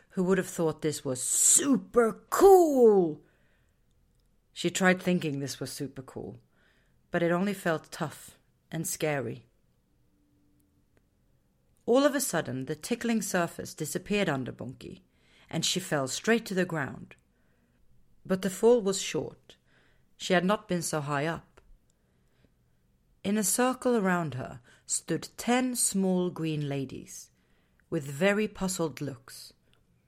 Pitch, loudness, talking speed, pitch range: 165 Hz, -28 LUFS, 130 wpm, 130-195 Hz